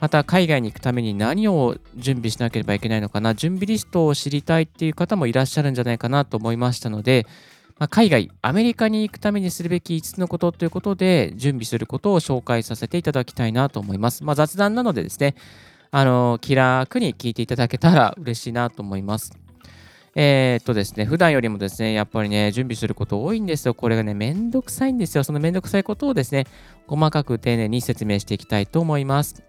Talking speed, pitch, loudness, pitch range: 465 characters per minute, 130 Hz, -21 LUFS, 115-165 Hz